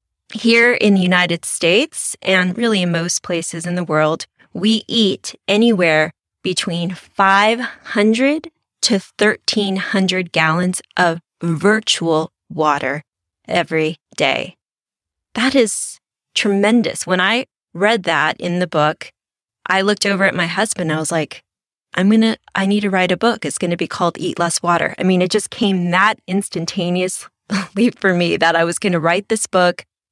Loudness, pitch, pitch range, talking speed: -17 LUFS, 185 Hz, 170-210 Hz, 160 wpm